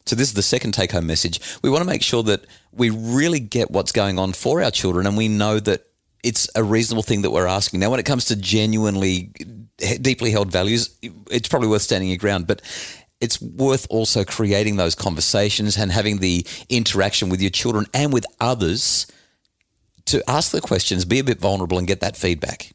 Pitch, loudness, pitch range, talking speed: 105 Hz, -20 LUFS, 95-115 Hz, 205 wpm